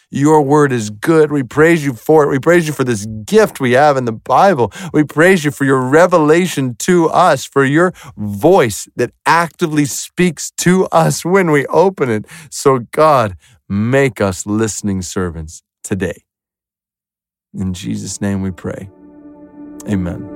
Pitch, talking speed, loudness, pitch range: 140 Hz, 155 wpm, -13 LUFS, 110-165 Hz